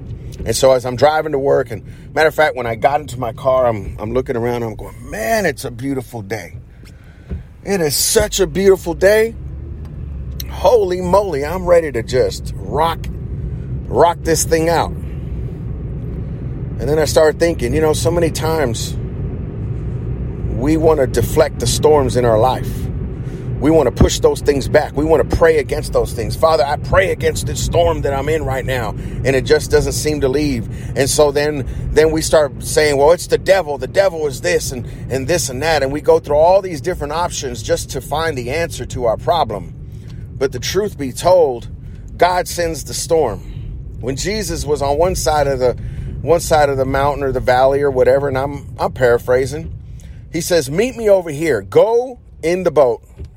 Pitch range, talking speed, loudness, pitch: 125-165 Hz, 195 wpm, -16 LUFS, 140 Hz